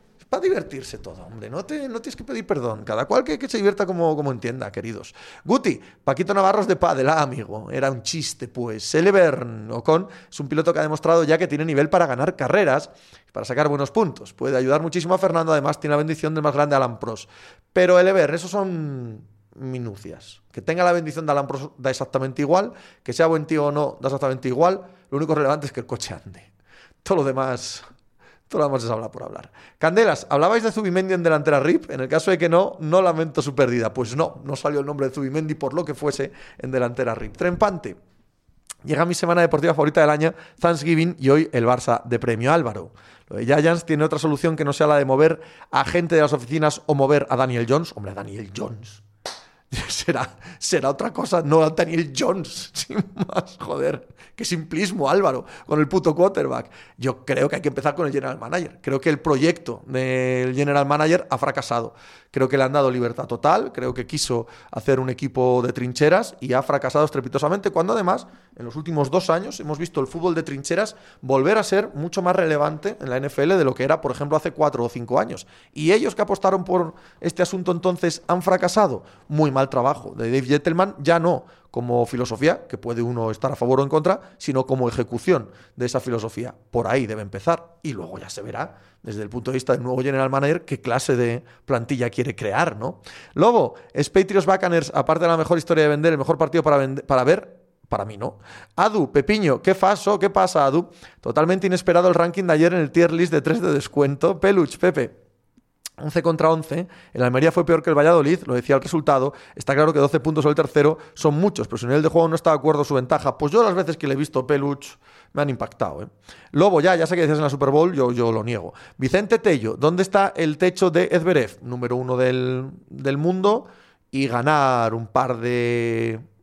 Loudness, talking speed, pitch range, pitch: -21 LUFS, 215 wpm, 130-170 Hz, 150 Hz